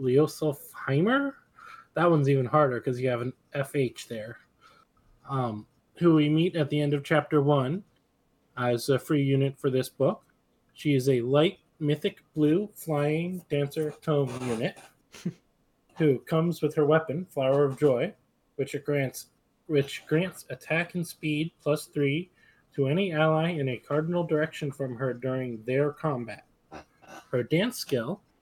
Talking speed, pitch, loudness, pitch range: 150 wpm, 145 Hz, -28 LUFS, 135-160 Hz